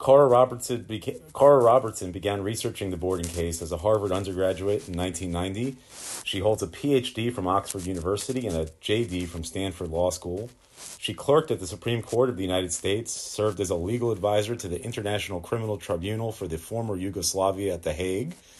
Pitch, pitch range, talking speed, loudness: 100 Hz, 90-115 Hz, 175 wpm, -26 LUFS